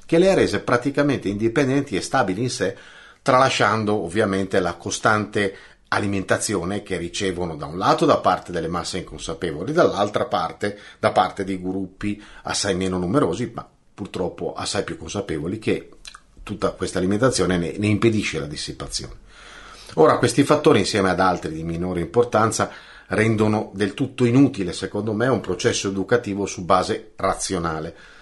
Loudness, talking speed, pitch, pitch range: -22 LUFS, 145 wpm, 100 Hz, 95-120 Hz